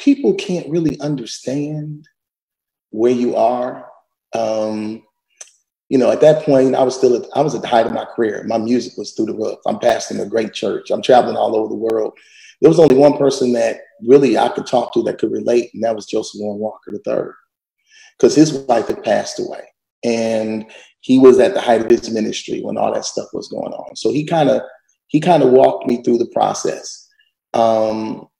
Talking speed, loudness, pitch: 205 wpm, -16 LUFS, 145 Hz